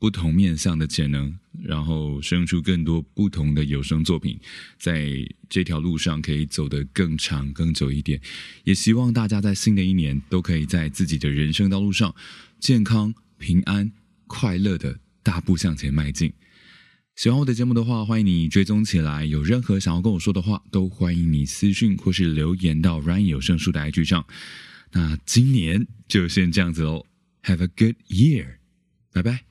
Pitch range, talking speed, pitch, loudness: 80-100 Hz, 285 characters per minute, 90 Hz, -22 LUFS